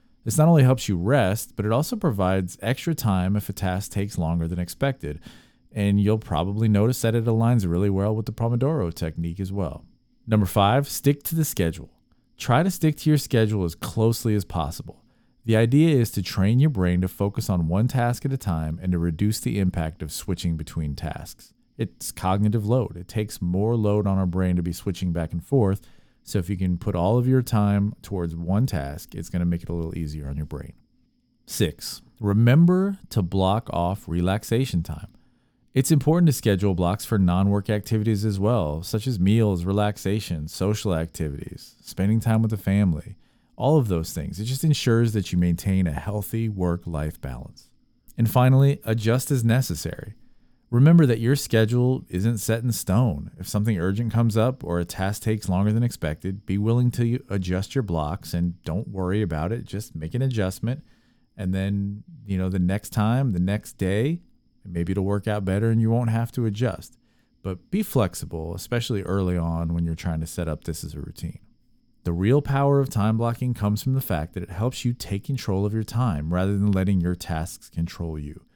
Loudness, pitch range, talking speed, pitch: -24 LUFS, 90-120 Hz, 200 wpm, 105 Hz